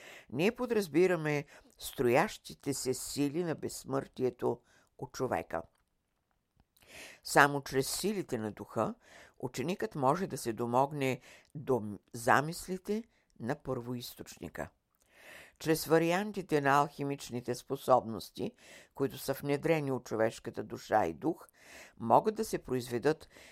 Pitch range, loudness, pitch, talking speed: 125-165 Hz, -33 LUFS, 140 Hz, 100 wpm